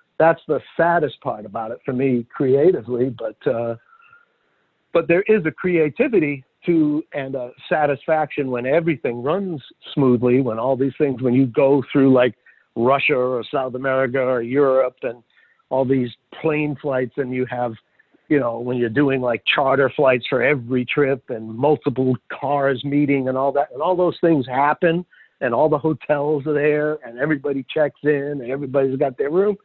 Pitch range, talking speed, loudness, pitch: 130-155 Hz, 170 wpm, -20 LUFS, 140 Hz